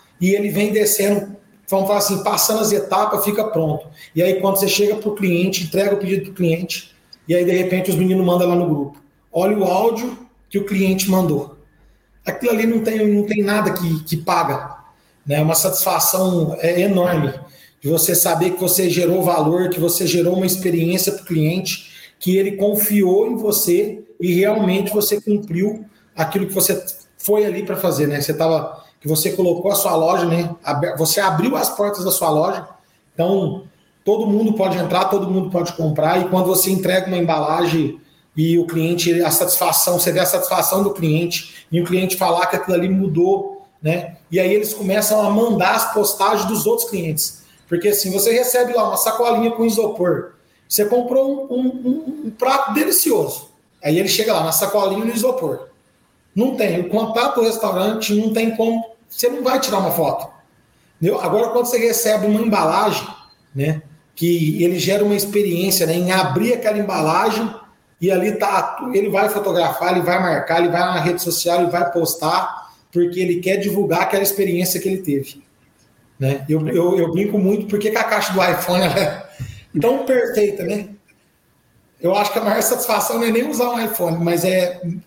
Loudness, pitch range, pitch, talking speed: -18 LUFS, 175-210 Hz, 190 Hz, 185 wpm